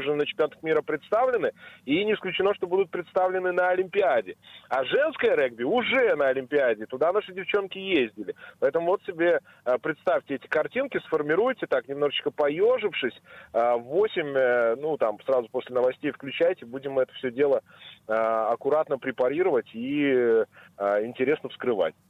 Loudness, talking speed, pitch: -26 LUFS, 140 wpm, 155 Hz